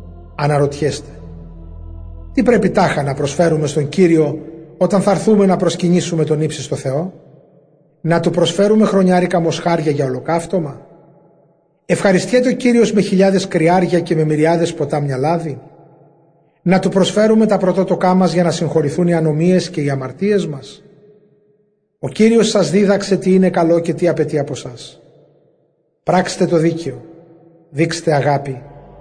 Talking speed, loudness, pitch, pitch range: 135 wpm, -15 LUFS, 170 Hz, 150-190 Hz